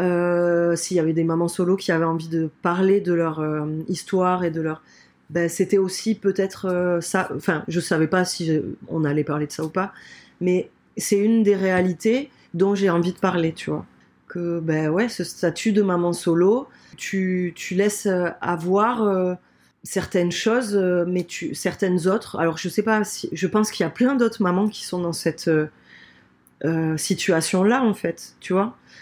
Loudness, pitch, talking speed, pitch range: -22 LUFS, 180 Hz, 190 wpm, 165-195 Hz